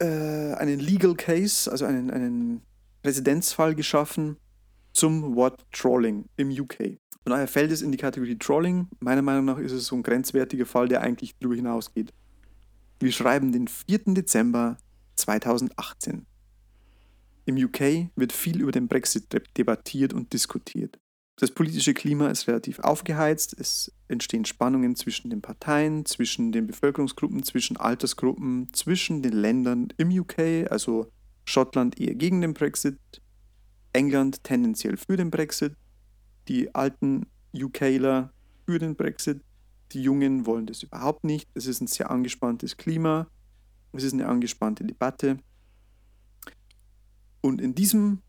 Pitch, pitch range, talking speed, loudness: 135 Hz, 115-160 Hz, 135 wpm, -26 LUFS